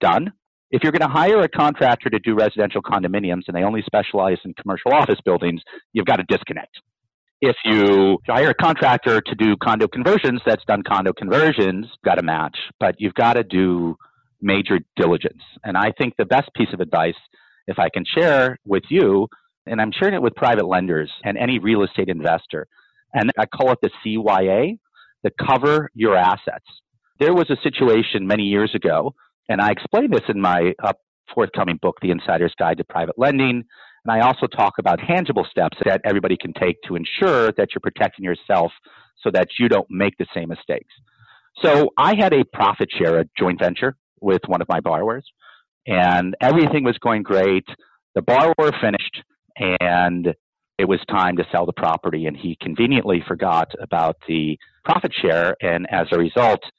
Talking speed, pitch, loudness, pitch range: 180 wpm, 105 Hz, -19 LUFS, 90-115 Hz